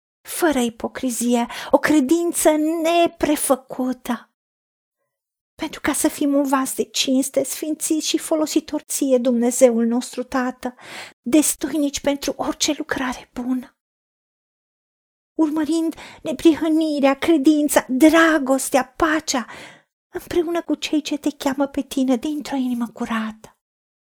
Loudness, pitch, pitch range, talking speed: -20 LUFS, 290 Hz, 255-315 Hz, 100 wpm